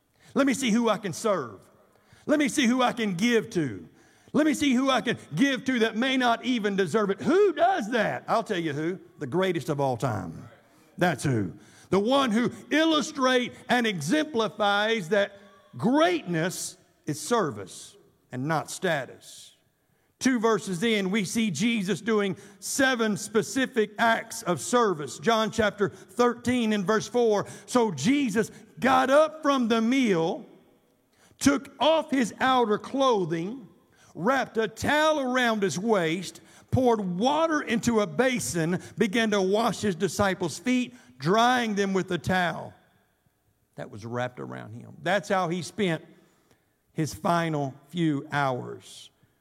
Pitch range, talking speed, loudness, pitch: 175-245 Hz, 145 wpm, -26 LUFS, 215 Hz